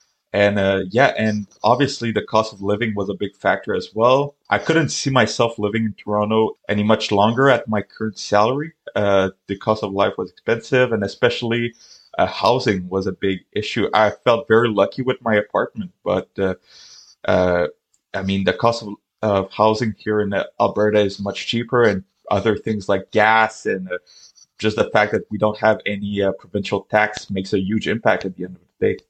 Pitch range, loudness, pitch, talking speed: 100-115 Hz, -19 LUFS, 105 Hz, 195 wpm